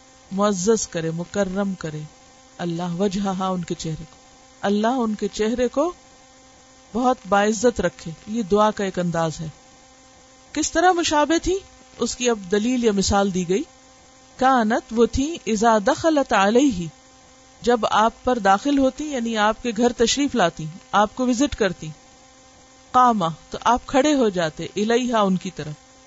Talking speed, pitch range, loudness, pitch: 130 wpm, 195-260 Hz, -21 LUFS, 235 Hz